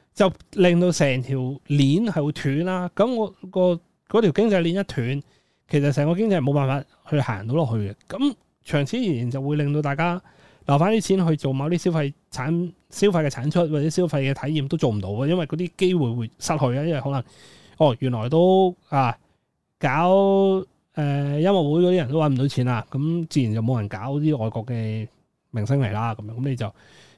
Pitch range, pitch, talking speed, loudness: 135-180 Hz, 150 Hz, 285 characters per minute, -22 LUFS